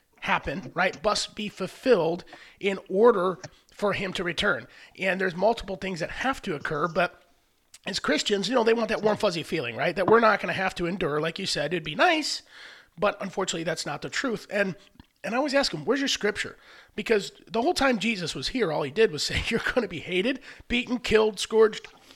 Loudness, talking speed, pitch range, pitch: -26 LUFS, 215 wpm, 180-230 Hz, 205 Hz